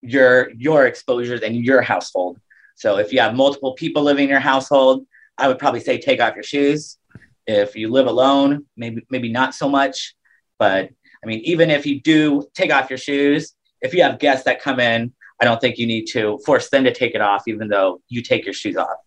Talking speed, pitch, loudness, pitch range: 220 wpm, 130 Hz, -18 LUFS, 115-140 Hz